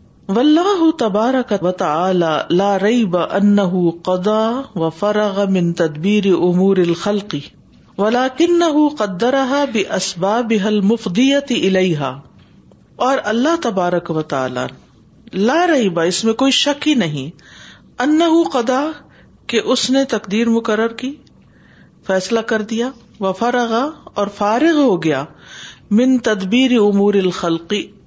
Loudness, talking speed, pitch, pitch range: -16 LUFS, 120 wpm, 215 Hz, 185-255 Hz